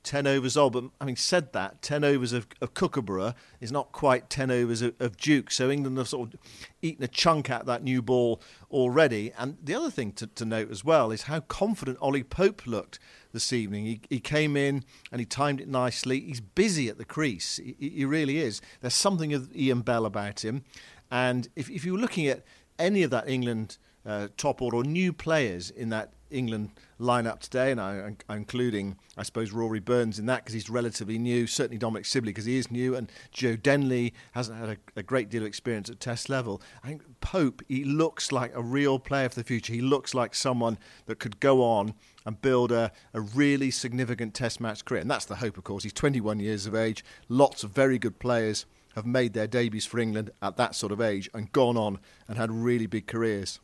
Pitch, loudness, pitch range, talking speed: 120 Hz, -28 LUFS, 110-135 Hz, 215 wpm